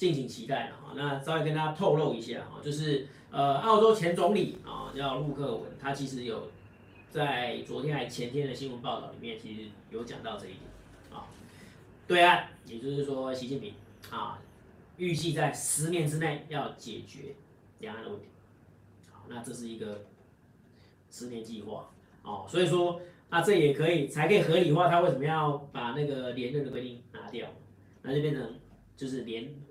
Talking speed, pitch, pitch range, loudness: 255 characters per minute, 140 Hz, 120-155 Hz, -30 LUFS